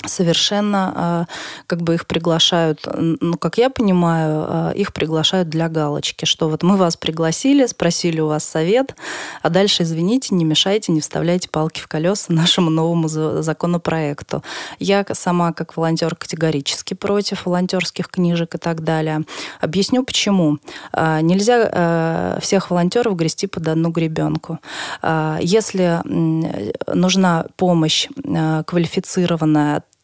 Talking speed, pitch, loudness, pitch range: 120 wpm, 170 Hz, -18 LUFS, 160-185 Hz